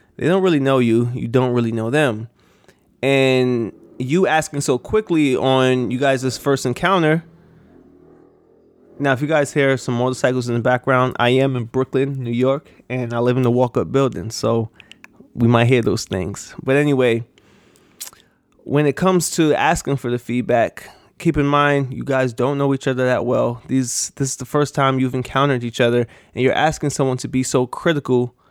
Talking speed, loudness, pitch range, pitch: 185 wpm, -18 LUFS, 125-145 Hz, 130 Hz